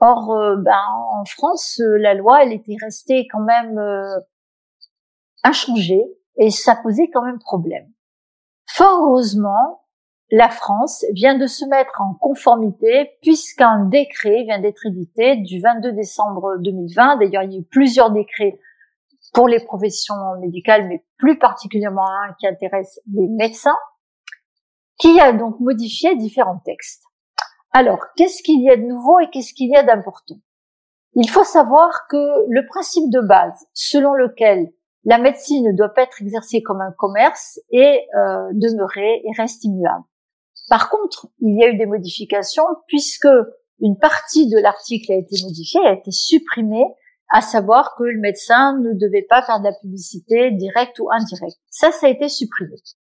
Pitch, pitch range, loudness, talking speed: 230 Hz, 205-275 Hz, -15 LUFS, 160 wpm